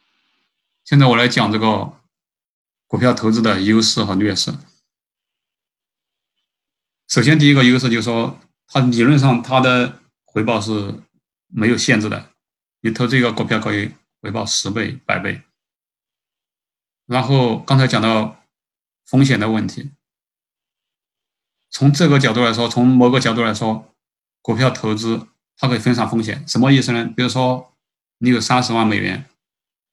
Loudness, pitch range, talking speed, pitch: -16 LUFS, 110-130 Hz, 215 characters per minute, 120 Hz